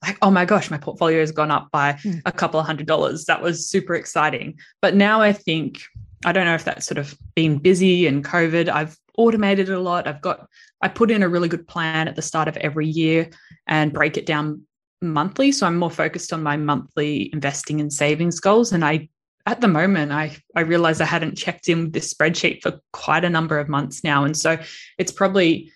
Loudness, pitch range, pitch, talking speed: -20 LUFS, 150-180 Hz, 165 Hz, 220 wpm